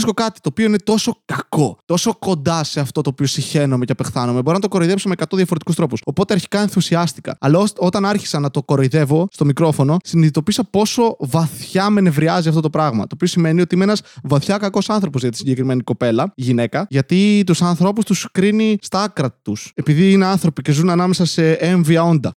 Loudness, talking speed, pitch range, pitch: -17 LUFS, 200 wpm, 145-195 Hz, 170 Hz